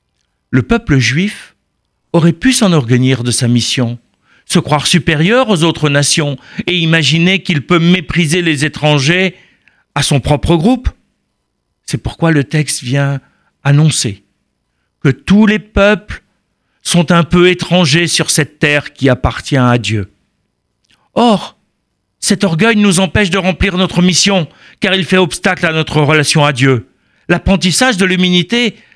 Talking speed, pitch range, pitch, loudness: 140 wpm, 140-185 Hz, 165 Hz, -11 LUFS